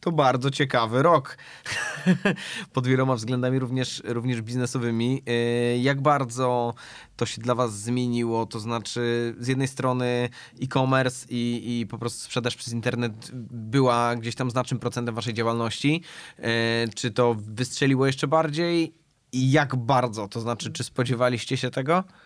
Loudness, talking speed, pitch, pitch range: -25 LUFS, 140 wpm, 125 Hz, 120-130 Hz